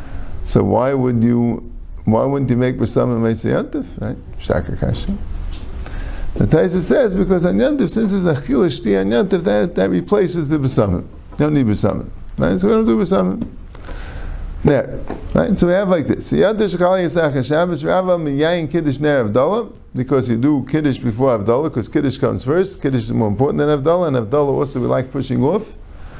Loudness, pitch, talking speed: -17 LUFS, 135 Hz, 150 wpm